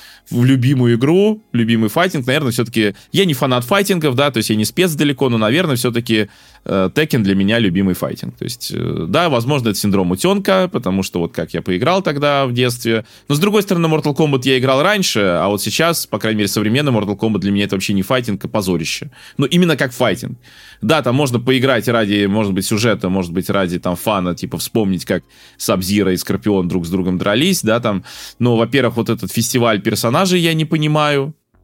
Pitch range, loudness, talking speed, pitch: 100-145 Hz, -16 LUFS, 205 wpm, 115 Hz